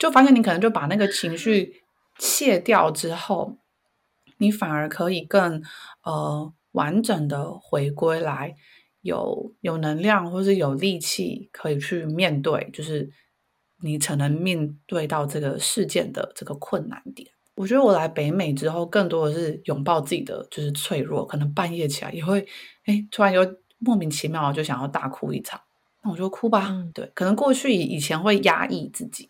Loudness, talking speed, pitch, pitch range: -23 LUFS, 250 characters per minute, 170 Hz, 150-200 Hz